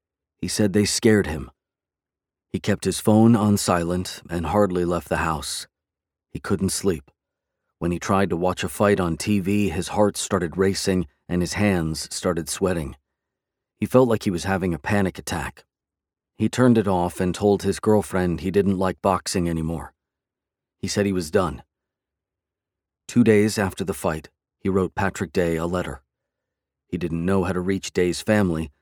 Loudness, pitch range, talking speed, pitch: -22 LUFS, 85-100 Hz, 175 wpm, 95 Hz